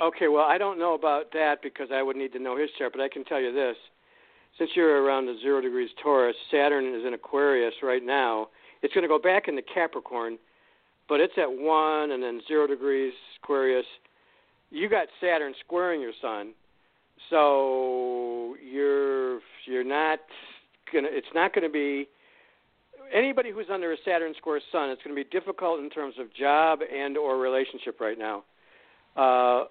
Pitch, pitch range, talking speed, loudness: 145 Hz, 130-175 Hz, 180 wpm, -27 LUFS